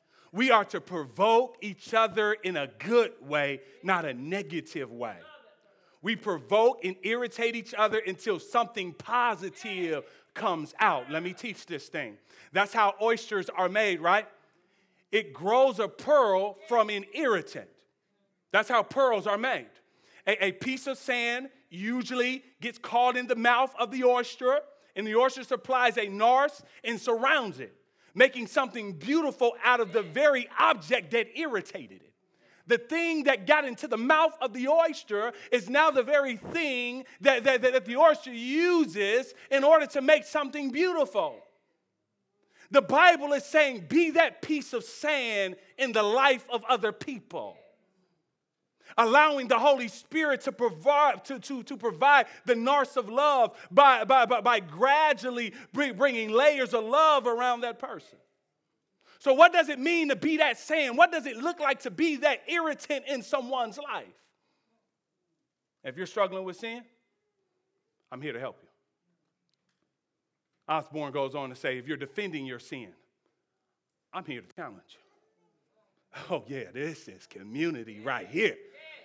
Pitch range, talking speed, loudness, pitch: 210-285 Hz, 155 wpm, -26 LUFS, 245 Hz